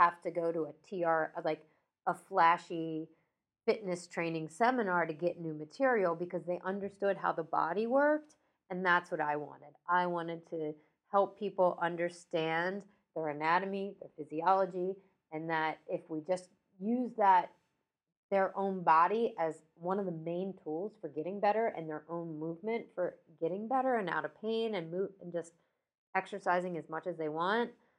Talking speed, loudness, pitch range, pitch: 165 wpm, -34 LUFS, 165-195 Hz, 175 Hz